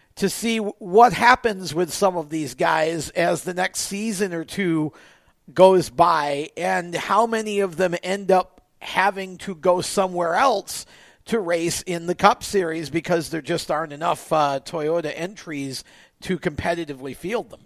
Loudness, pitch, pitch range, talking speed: -22 LUFS, 180 Hz, 165-195 Hz, 160 wpm